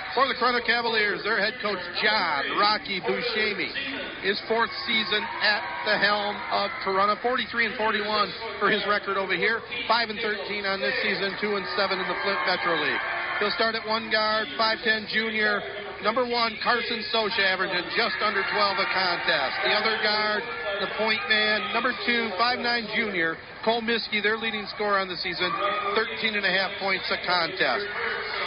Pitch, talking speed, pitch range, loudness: 215 Hz, 175 wpm, 200-230 Hz, -24 LUFS